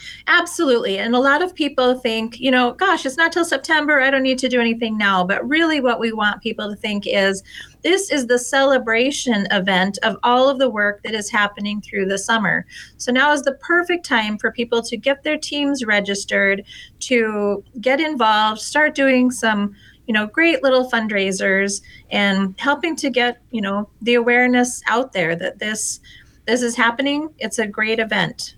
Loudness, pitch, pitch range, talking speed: -18 LUFS, 235 Hz, 210-275 Hz, 185 wpm